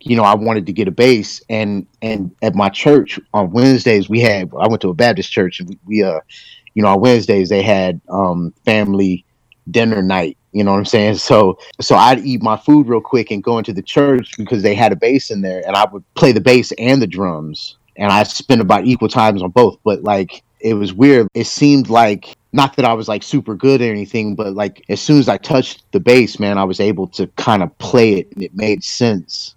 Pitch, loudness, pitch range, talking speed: 110 Hz, -14 LUFS, 100-120 Hz, 240 wpm